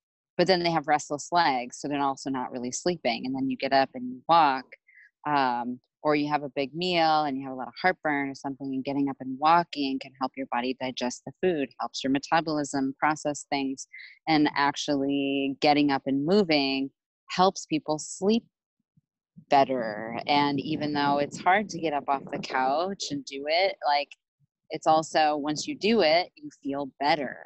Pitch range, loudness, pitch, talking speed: 135-160 Hz, -27 LUFS, 145 Hz, 190 wpm